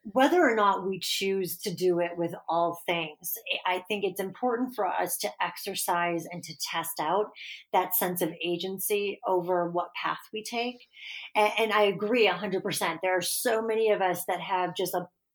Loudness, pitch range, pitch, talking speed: -28 LUFS, 175-210 Hz, 190 Hz, 190 wpm